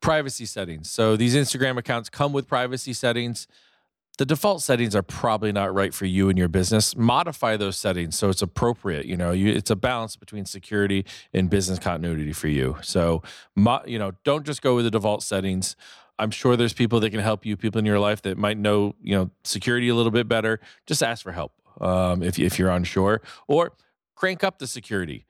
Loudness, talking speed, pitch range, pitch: -24 LUFS, 205 wpm, 95-120 Hz, 105 Hz